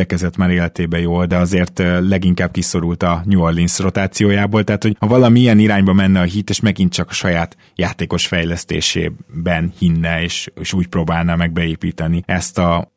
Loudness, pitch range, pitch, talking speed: -16 LUFS, 85-95 Hz, 90 Hz, 155 wpm